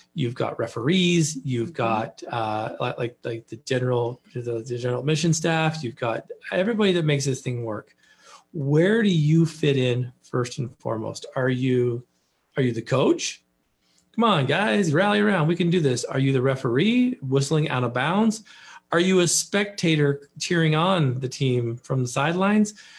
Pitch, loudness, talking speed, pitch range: 140 Hz, -23 LUFS, 170 wpm, 125-175 Hz